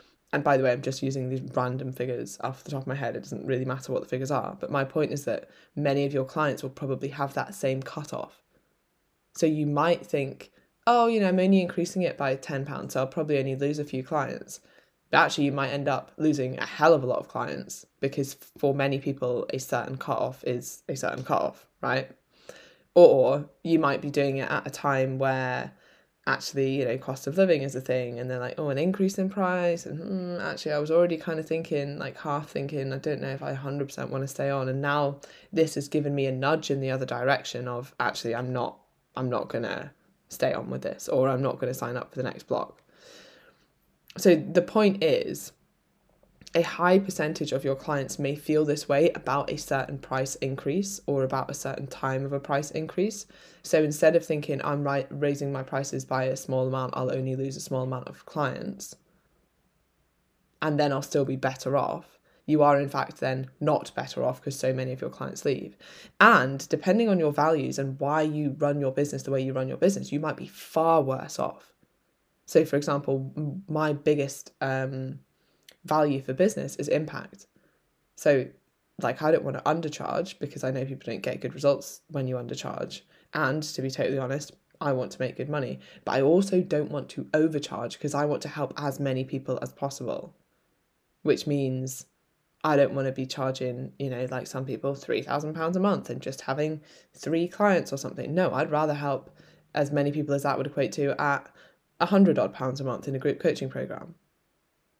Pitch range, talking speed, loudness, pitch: 135-155 Hz, 210 wpm, -27 LUFS, 140 Hz